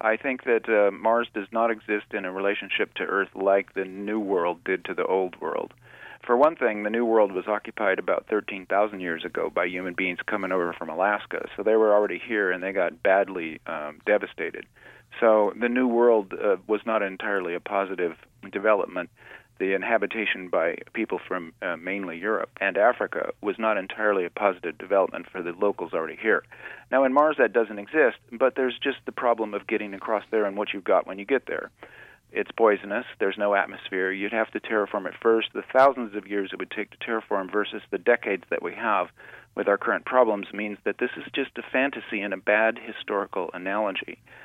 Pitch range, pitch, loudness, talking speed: 100-115 Hz, 105 Hz, -25 LUFS, 200 wpm